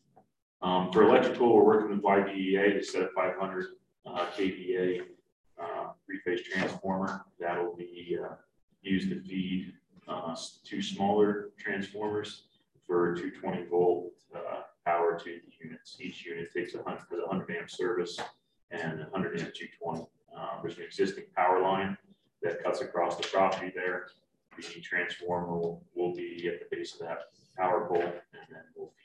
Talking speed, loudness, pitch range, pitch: 155 wpm, -31 LUFS, 90-105 Hz, 95 Hz